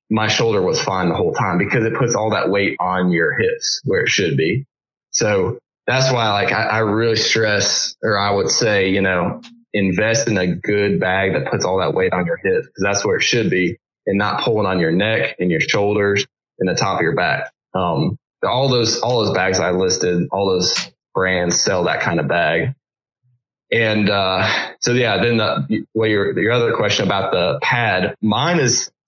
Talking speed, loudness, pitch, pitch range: 205 wpm, -17 LUFS, 110 Hz, 100-130 Hz